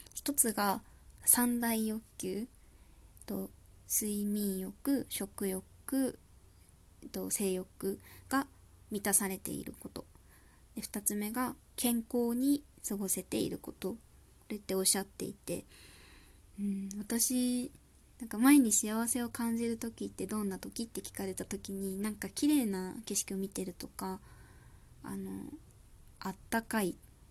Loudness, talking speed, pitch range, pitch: -34 LUFS, 220 characters per minute, 185-235 Hz, 205 Hz